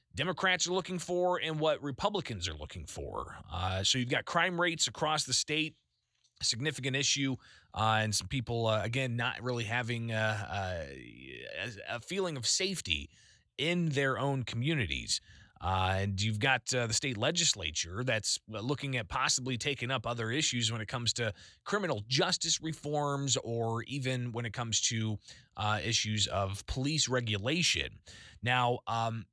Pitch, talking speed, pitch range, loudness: 125 Hz, 160 wpm, 110-145 Hz, -32 LUFS